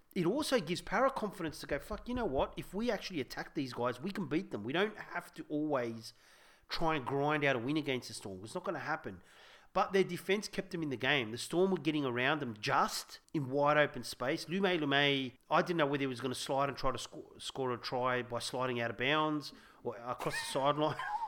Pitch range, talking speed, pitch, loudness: 130-180 Hz, 245 wpm, 150 Hz, -35 LUFS